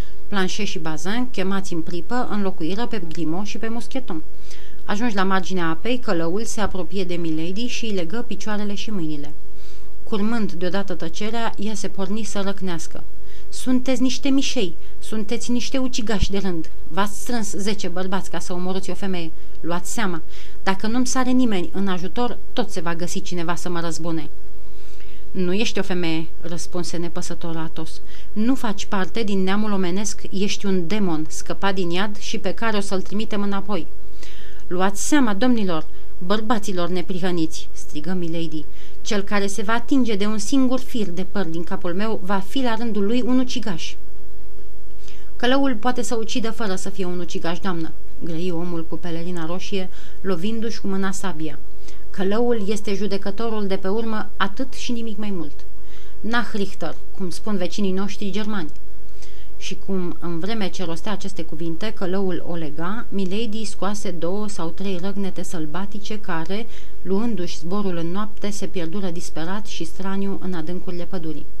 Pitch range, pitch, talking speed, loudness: 175-215 Hz, 195 Hz, 160 wpm, -26 LUFS